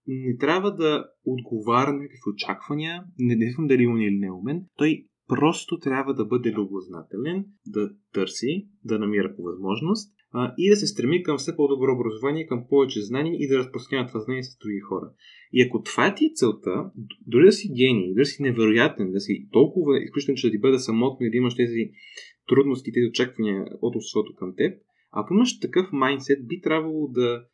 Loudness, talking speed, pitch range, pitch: -24 LUFS, 190 wpm, 115-150 Hz, 130 Hz